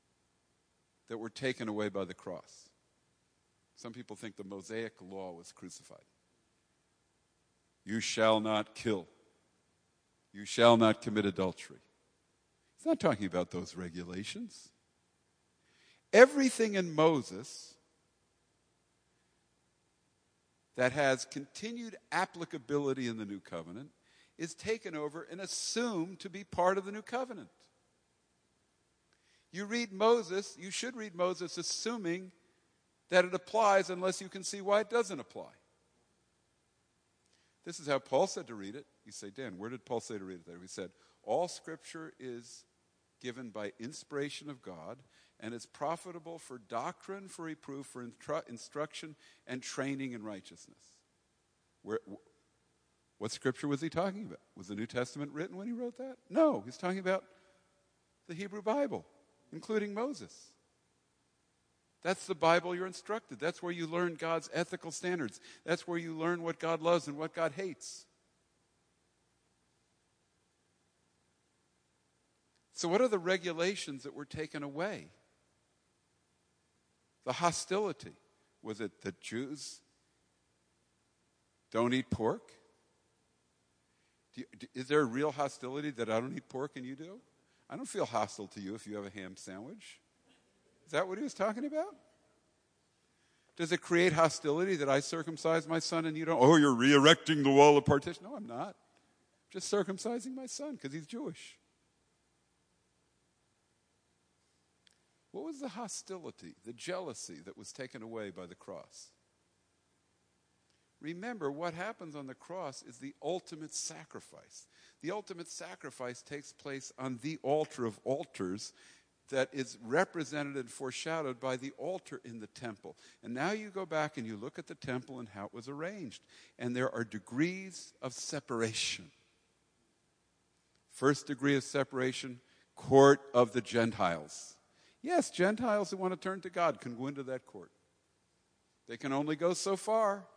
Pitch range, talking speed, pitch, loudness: 120-185 Hz, 145 wpm, 150 Hz, -34 LUFS